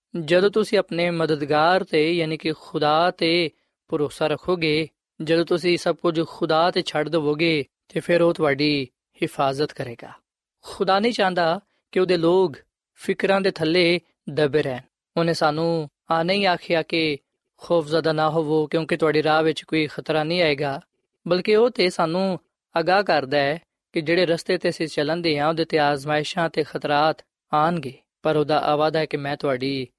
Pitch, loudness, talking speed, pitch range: 165 Hz, -22 LUFS, 160 wpm, 150-175 Hz